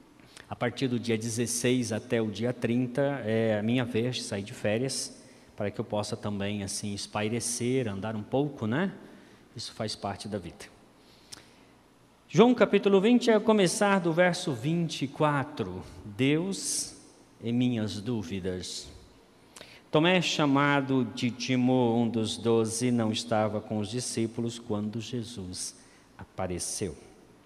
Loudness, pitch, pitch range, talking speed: -28 LUFS, 120 Hz, 110-135 Hz, 135 wpm